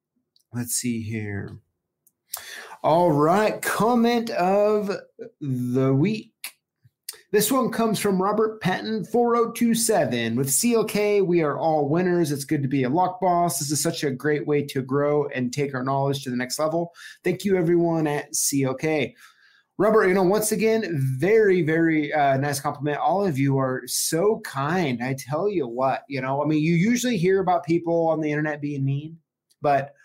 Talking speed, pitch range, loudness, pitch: 170 wpm, 140-195 Hz, -23 LUFS, 160 Hz